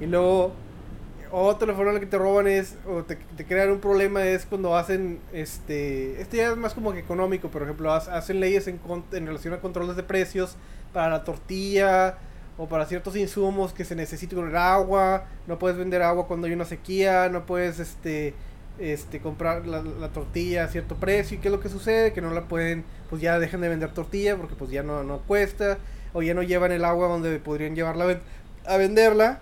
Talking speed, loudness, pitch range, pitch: 210 wpm, -25 LUFS, 165-195 Hz, 180 Hz